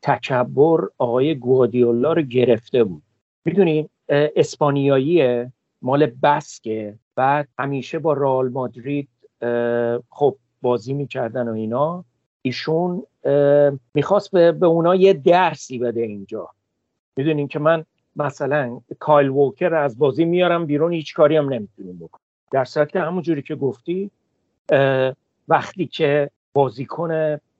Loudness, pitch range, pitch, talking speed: -19 LUFS, 125-160 Hz, 140 Hz, 115 wpm